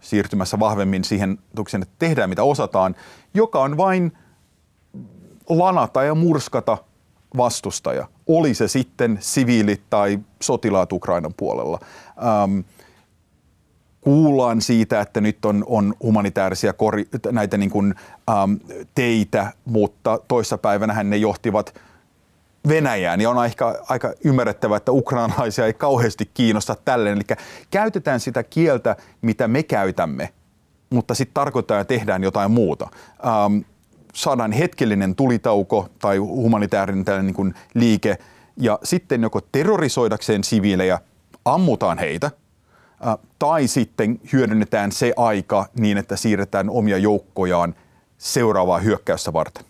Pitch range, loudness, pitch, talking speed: 100-125 Hz, -20 LUFS, 110 Hz, 105 wpm